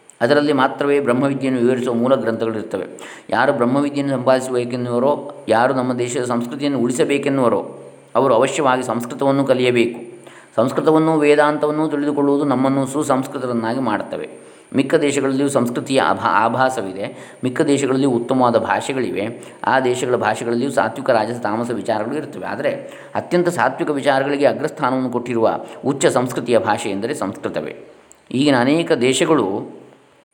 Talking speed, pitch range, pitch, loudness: 110 wpm, 120-140 Hz, 130 Hz, -18 LUFS